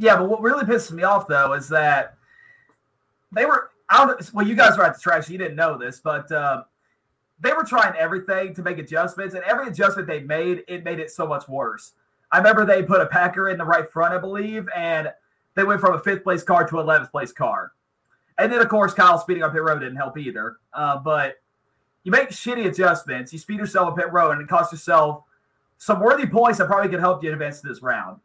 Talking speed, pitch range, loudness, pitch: 225 wpm, 155-200 Hz, -20 LUFS, 180 Hz